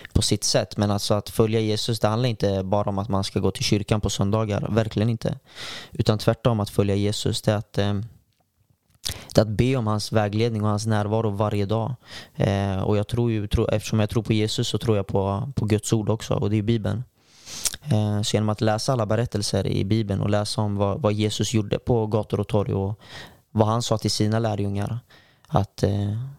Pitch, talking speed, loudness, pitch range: 105 Hz, 220 wpm, -24 LUFS, 105-115 Hz